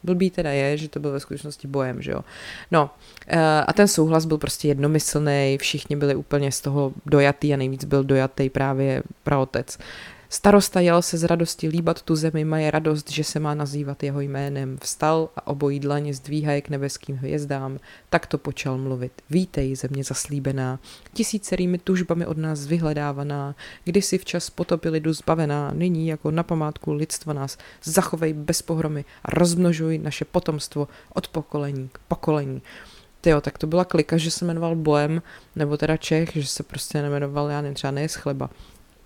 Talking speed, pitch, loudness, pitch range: 165 wpm, 150 Hz, -23 LUFS, 140-160 Hz